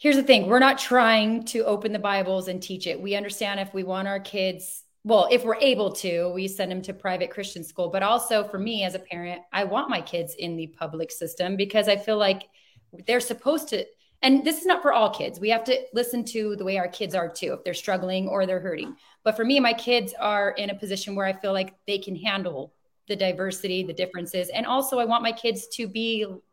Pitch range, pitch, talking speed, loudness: 185-230 Hz, 200 Hz, 240 wpm, -25 LUFS